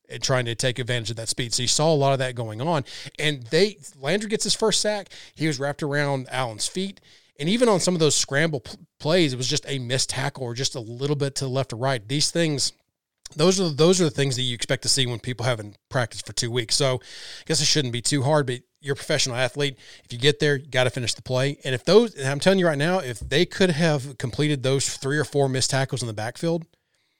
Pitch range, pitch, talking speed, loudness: 125-155 Hz, 140 Hz, 265 wpm, -23 LUFS